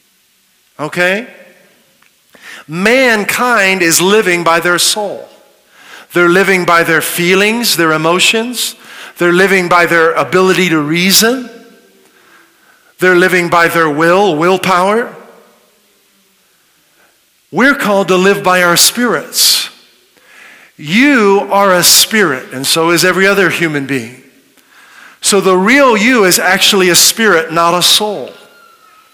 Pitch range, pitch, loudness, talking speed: 170-210 Hz, 185 Hz, -9 LUFS, 115 wpm